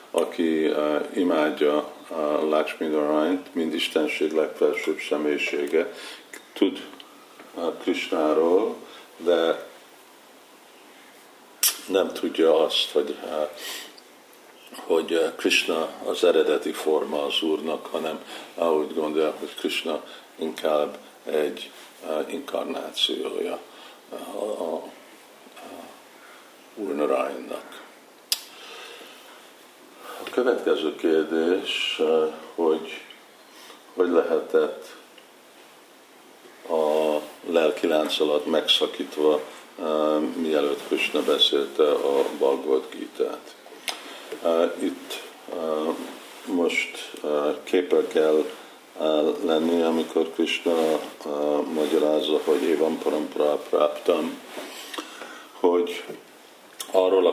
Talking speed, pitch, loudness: 75 wpm, 390 Hz, -24 LUFS